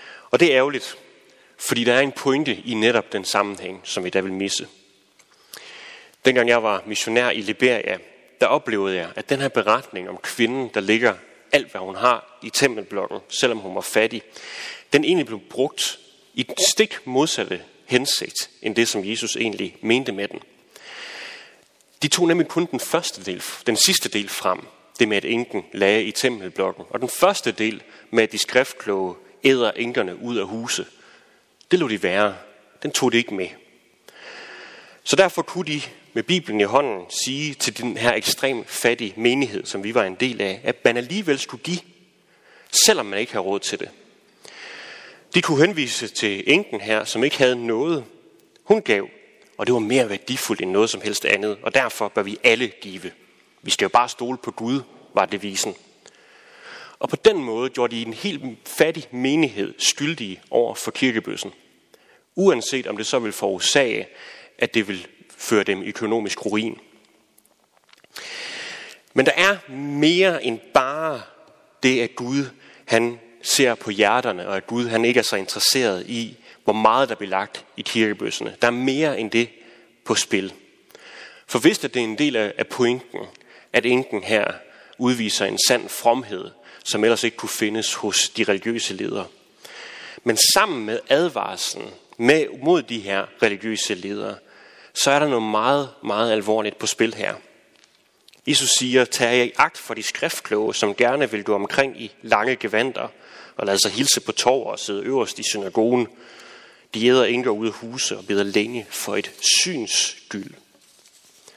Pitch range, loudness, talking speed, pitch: 110-140 Hz, -21 LUFS, 170 wpm, 120 Hz